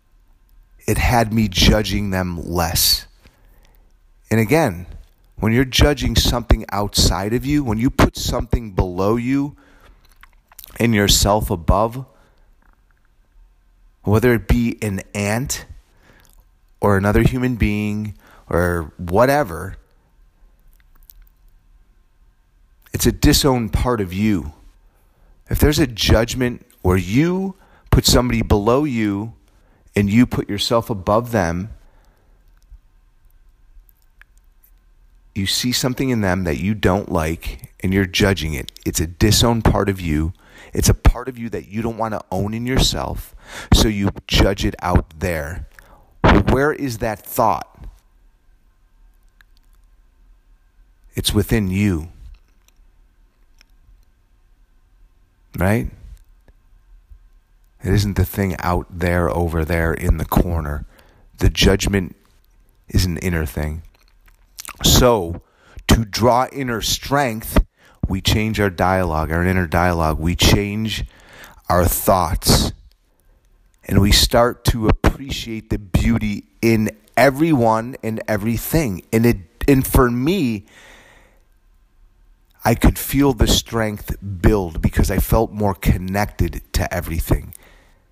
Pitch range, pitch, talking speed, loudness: 85-110 Hz, 95 Hz, 110 wpm, -18 LUFS